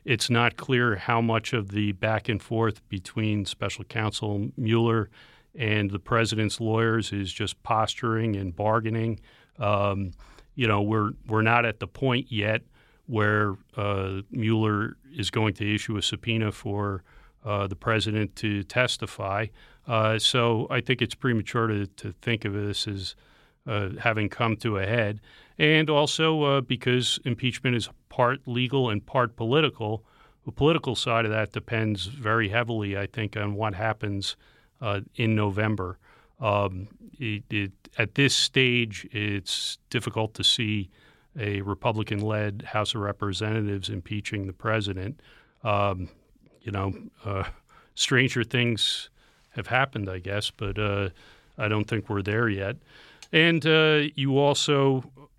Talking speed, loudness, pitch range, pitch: 145 wpm, -26 LUFS, 105-120 Hz, 110 Hz